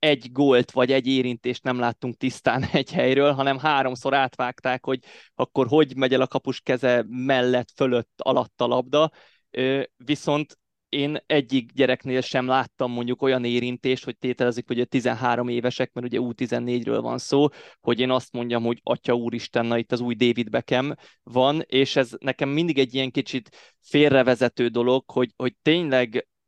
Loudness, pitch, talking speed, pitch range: -23 LUFS, 130 Hz, 165 wpm, 125-135 Hz